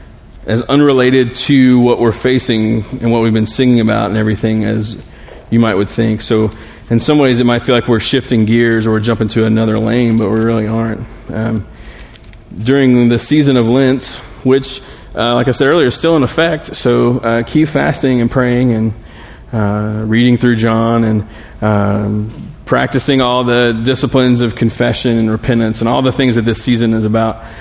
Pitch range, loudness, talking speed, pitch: 110-125 Hz, -12 LUFS, 185 wpm, 115 Hz